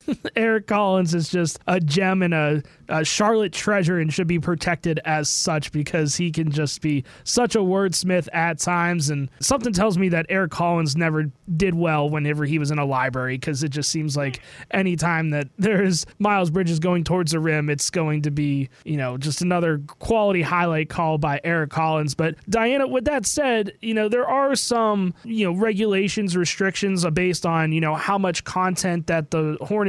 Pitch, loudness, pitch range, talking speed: 170 Hz, -22 LUFS, 155-195 Hz, 190 wpm